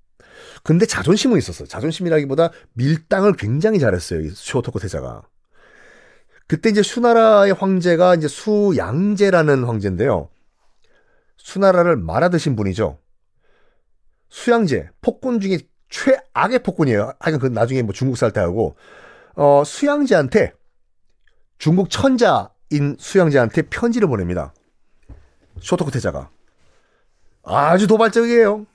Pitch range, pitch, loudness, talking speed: 140-210 Hz, 175 Hz, -17 LUFS, 280 characters per minute